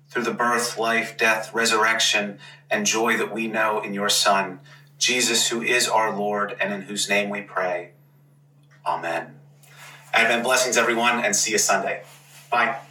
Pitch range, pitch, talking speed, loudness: 105-120 Hz, 115 Hz, 160 wpm, -21 LUFS